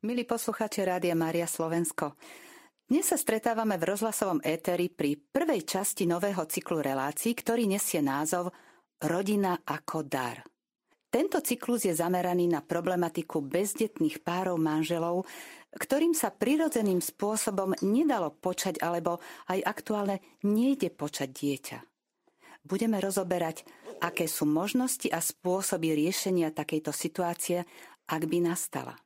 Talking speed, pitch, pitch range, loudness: 120 wpm, 180 Hz, 165-225 Hz, -30 LUFS